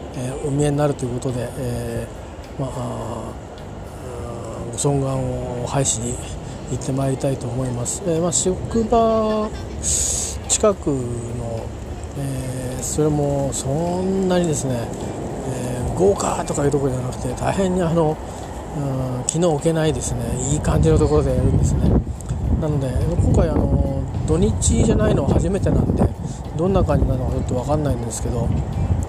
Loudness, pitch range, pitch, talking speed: -21 LUFS, 115-150 Hz, 130 Hz, 315 characters per minute